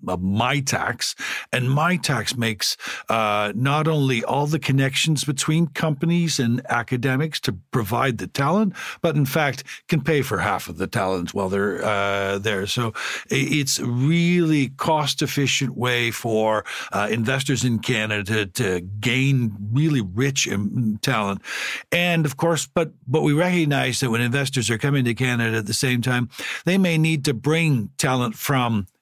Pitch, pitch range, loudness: 130 Hz, 110-150 Hz, -22 LUFS